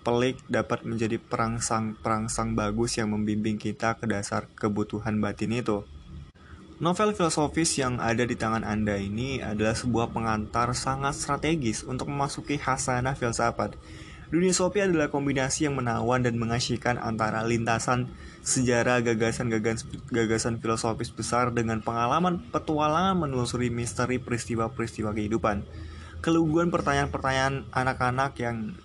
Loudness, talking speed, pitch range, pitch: -27 LUFS, 115 wpm, 110-135 Hz, 120 Hz